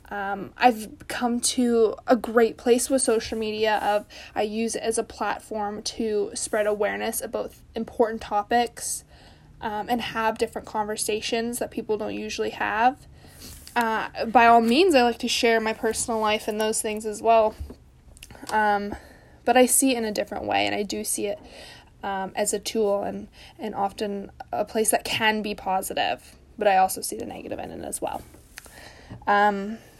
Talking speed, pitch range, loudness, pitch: 175 wpm, 205-230 Hz, -24 LUFS, 220 Hz